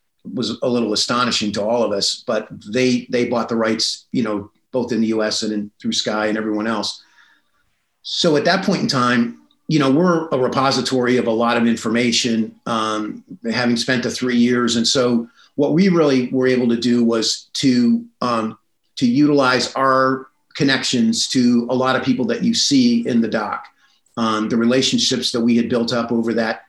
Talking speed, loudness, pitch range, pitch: 195 wpm, -18 LUFS, 115-135 Hz, 120 Hz